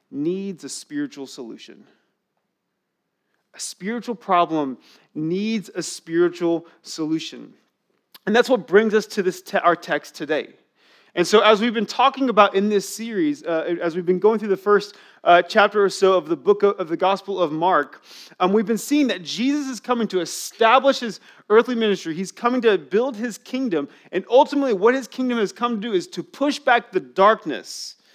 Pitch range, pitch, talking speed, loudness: 175-240 Hz, 205 Hz, 185 wpm, -20 LUFS